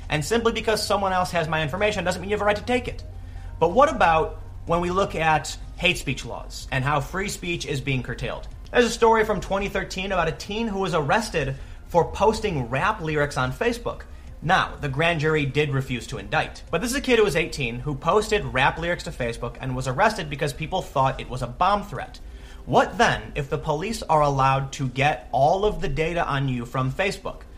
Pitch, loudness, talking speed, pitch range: 155 Hz, -23 LUFS, 220 wpm, 135-195 Hz